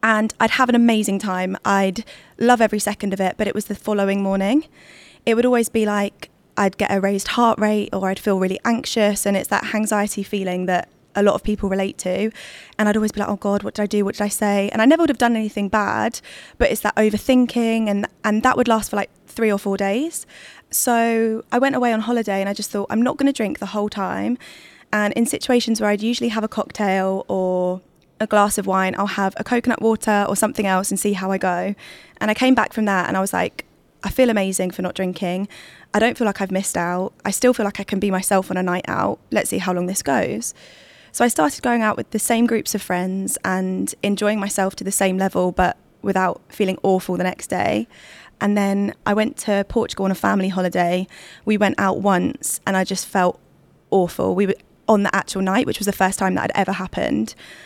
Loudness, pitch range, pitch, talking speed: -20 LUFS, 190-220 Hz, 205 Hz, 240 wpm